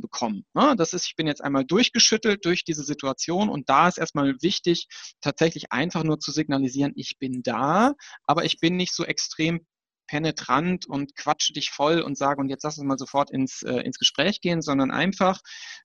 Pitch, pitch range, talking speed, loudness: 160 Hz, 140-180 Hz, 190 wpm, -24 LUFS